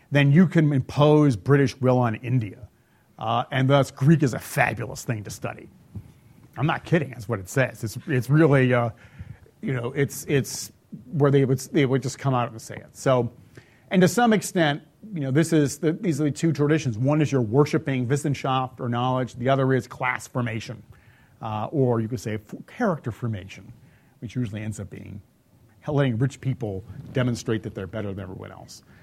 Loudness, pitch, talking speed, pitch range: -24 LUFS, 130 Hz, 190 wpm, 115-145 Hz